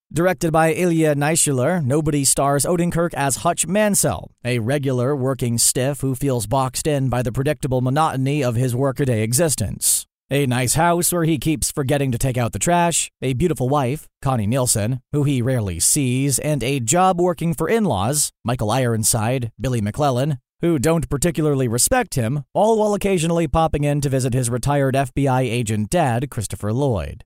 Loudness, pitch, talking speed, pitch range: -19 LUFS, 140 Hz, 165 wpm, 125-160 Hz